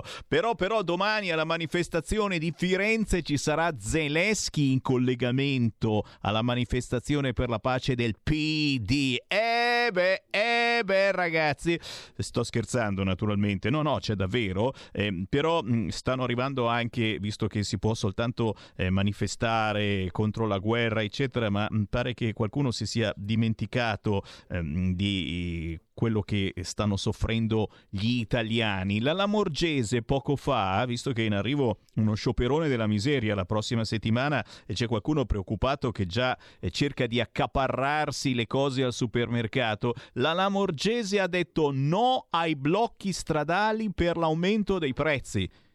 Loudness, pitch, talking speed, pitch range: -27 LUFS, 125 Hz, 140 wpm, 110-155 Hz